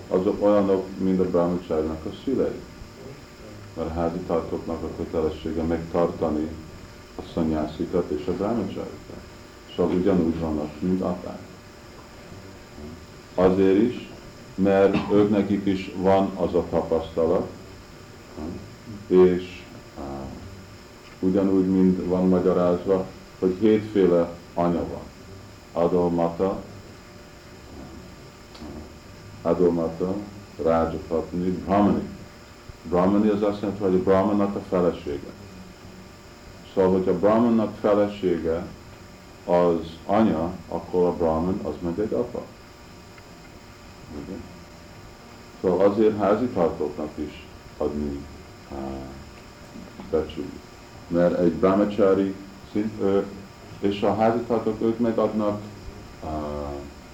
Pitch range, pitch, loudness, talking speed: 85-105 Hz, 95 Hz, -24 LUFS, 95 wpm